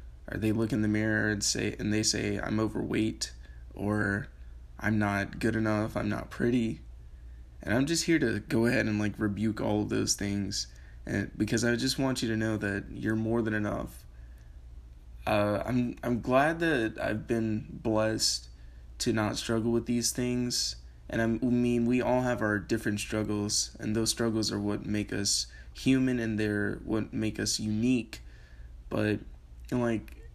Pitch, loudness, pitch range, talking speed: 105 Hz, -30 LUFS, 85-115 Hz, 175 wpm